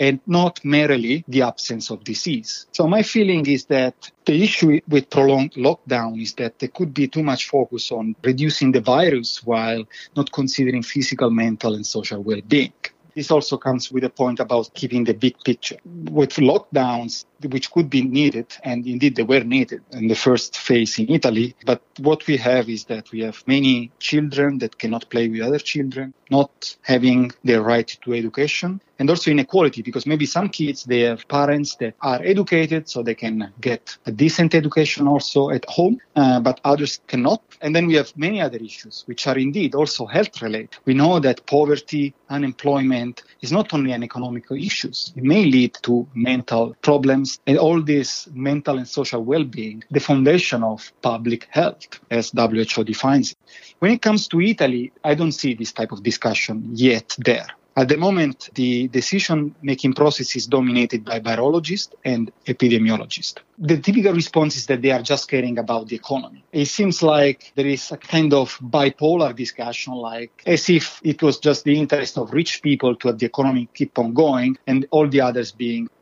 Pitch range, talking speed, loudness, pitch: 120-150 Hz, 185 wpm, -20 LUFS, 135 Hz